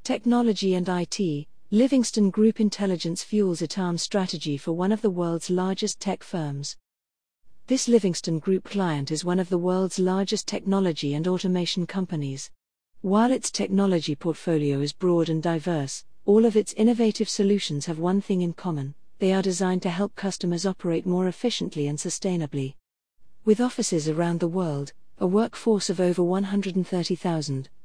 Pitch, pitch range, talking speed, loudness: 185 Hz, 165-200 Hz, 150 wpm, -25 LUFS